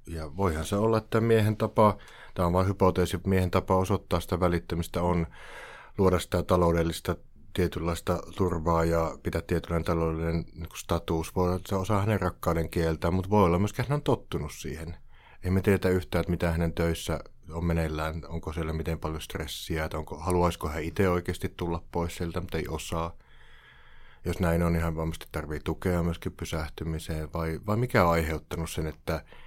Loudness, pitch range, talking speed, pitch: -29 LUFS, 80-95 Hz, 175 wpm, 85 Hz